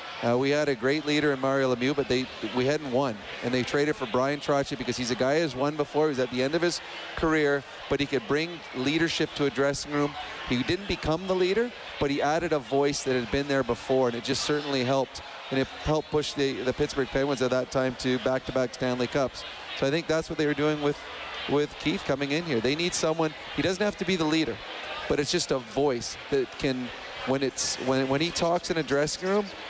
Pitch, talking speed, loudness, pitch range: 140 Hz, 240 wpm, -27 LUFS, 130-155 Hz